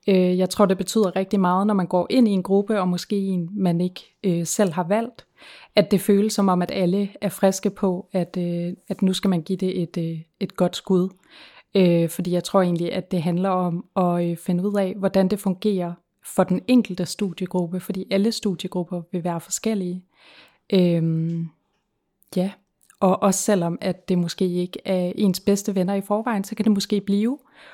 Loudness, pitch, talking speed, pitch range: -22 LUFS, 185 Hz, 200 wpm, 180-200 Hz